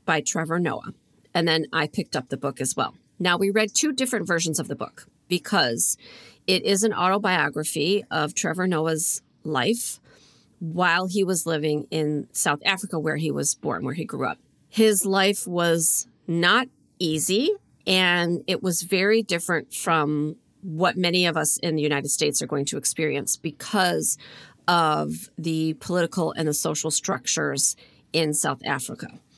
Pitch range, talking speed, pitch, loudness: 150-185 Hz, 160 wpm, 165 Hz, -23 LUFS